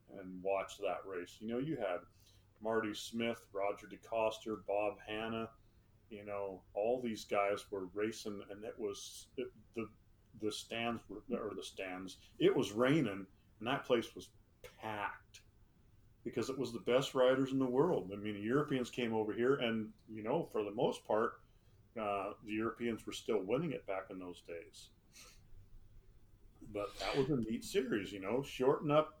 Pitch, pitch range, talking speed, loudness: 105 Hz, 100-115 Hz, 170 wpm, -39 LUFS